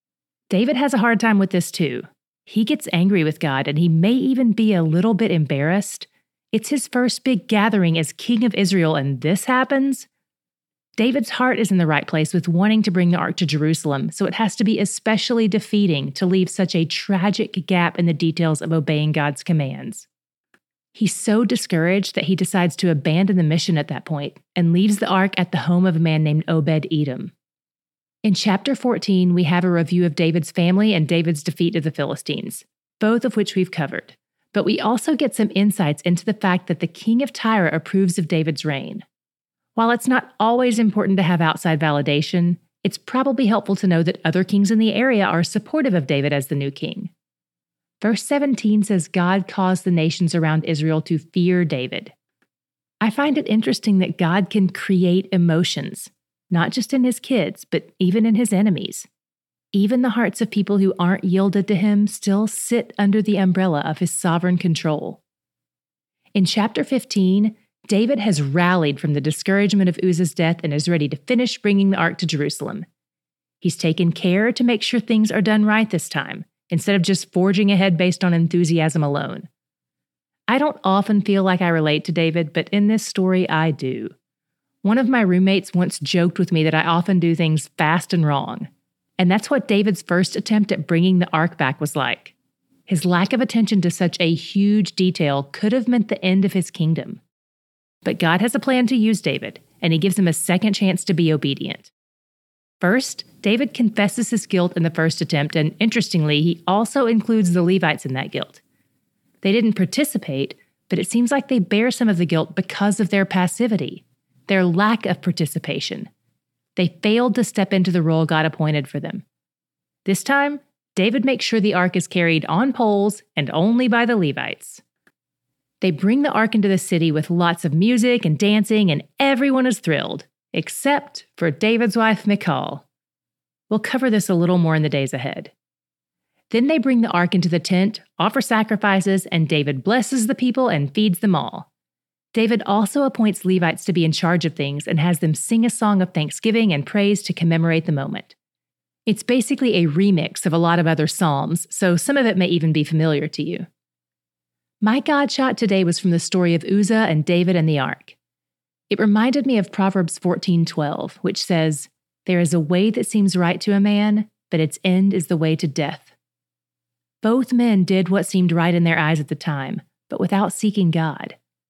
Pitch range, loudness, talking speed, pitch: 165-215 Hz, -19 LUFS, 195 wpm, 185 Hz